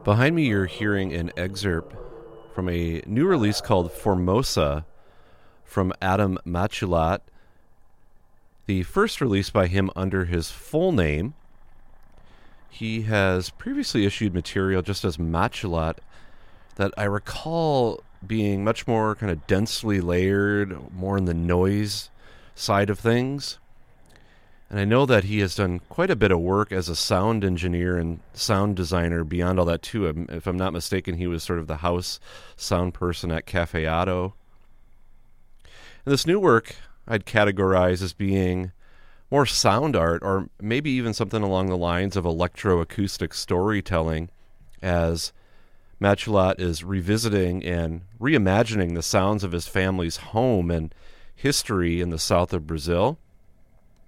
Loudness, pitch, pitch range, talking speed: -24 LUFS, 95 Hz, 85-105 Hz, 140 wpm